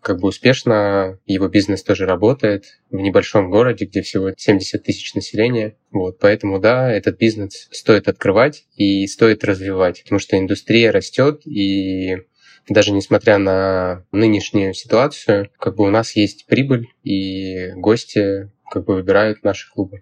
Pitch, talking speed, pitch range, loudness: 100 Hz, 145 wpm, 95-110 Hz, -17 LUFS